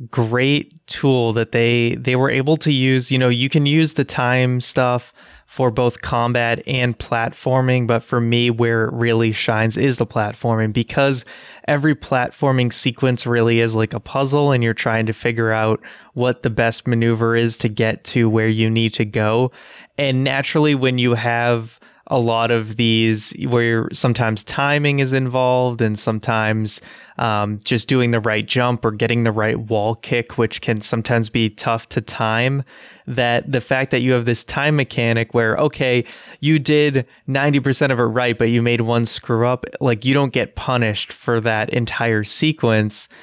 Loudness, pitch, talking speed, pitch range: -18 LUFS, 120 Hz, 175 wpm, 115-130 Hz